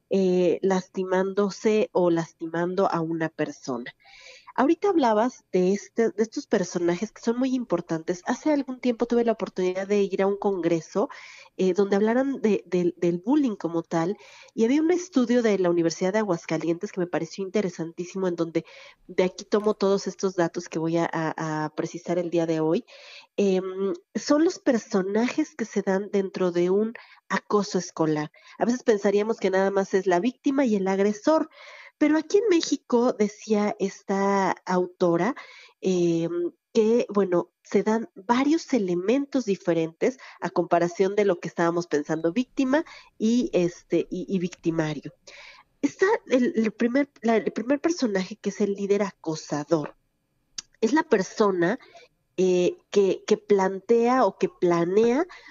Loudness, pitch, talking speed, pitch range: -25 LUFS, 195 Hz, 155 wpm, 175-235 Hz